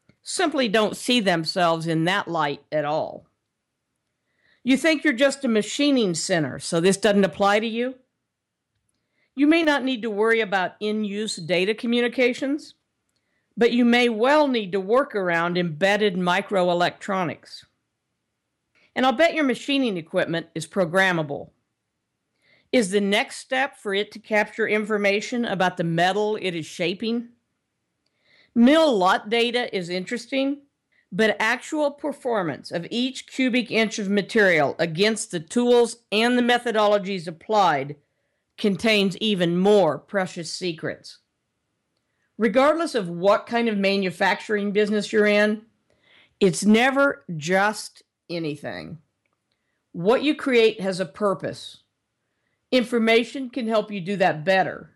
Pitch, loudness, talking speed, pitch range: 210 Hz, -22 LUFS, 130 wpm, 185-245 Hz